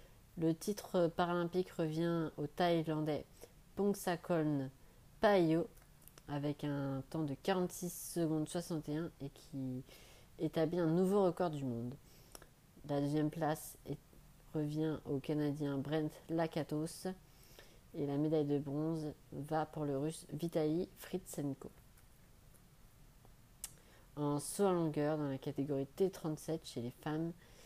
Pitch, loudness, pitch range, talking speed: 155 Hz, -38 LUFS, 140-165 Hz, 115 wpm